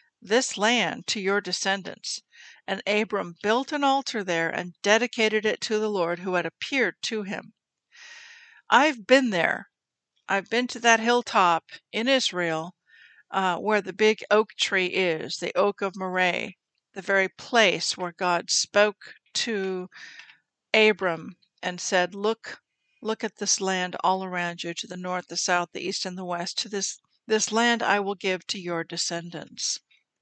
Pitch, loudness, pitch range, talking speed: 200 Hz, -25 LUFS, 180-220 Hz, 160 wpm